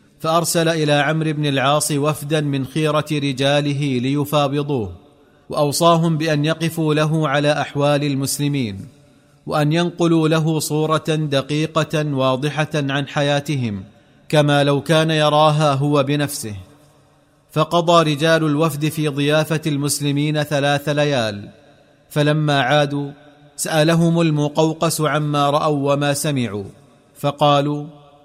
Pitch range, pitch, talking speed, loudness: 145-155 Hz, 145 Hz, 100 wpm, -18 LUFS